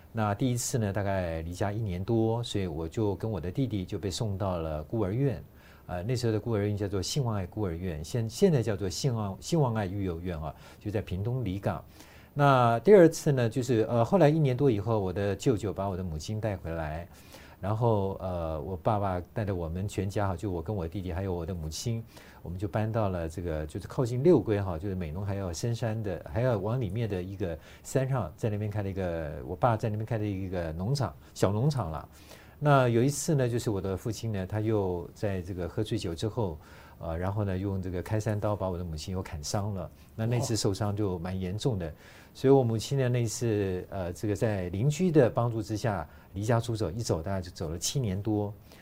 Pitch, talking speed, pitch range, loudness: 105 Hz, 315 characters per minute, 90-115 Hz, -30 LUFS